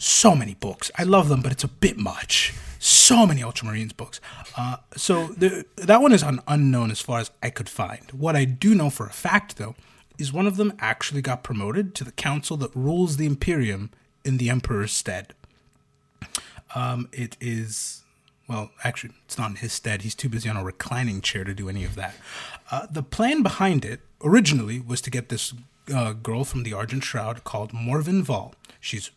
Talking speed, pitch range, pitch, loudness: 200 wpm, 115-150 Hz, 125 Hz, -23 LUFS